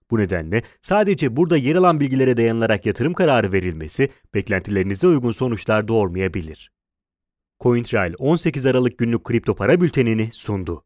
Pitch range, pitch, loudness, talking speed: 95-135 Hz, 115 Hz, -19 LUFS, 125 wpm